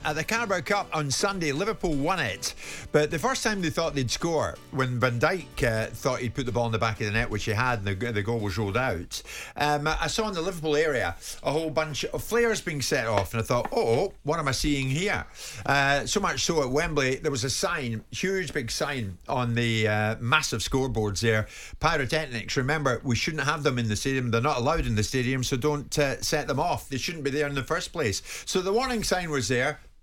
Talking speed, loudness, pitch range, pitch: 240 wpm, -27 LUFS, 120-155 Hz, 140 Hz